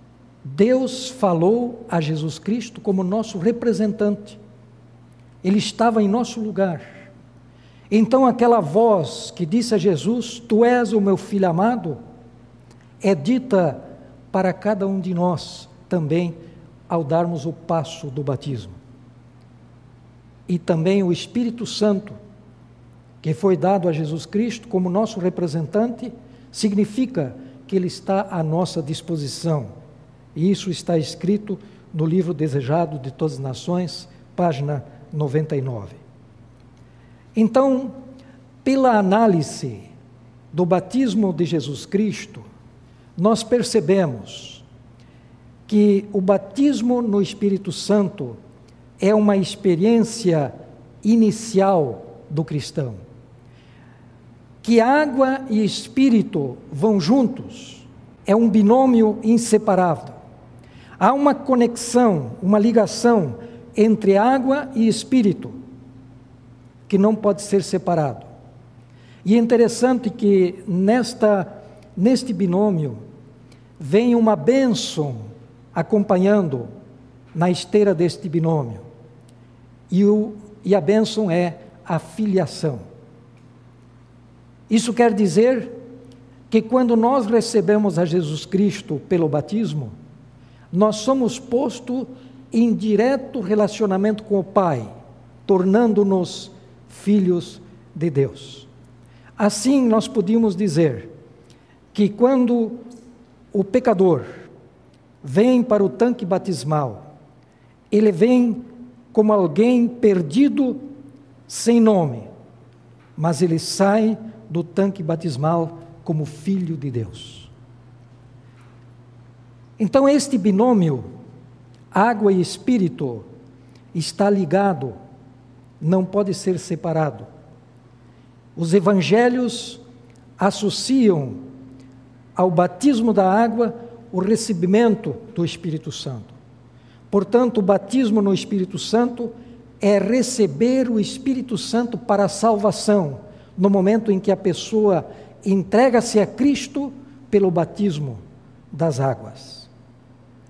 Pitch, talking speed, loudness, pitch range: 180 Hz, 100 wpm, -19 LUFS, 130-215 Hz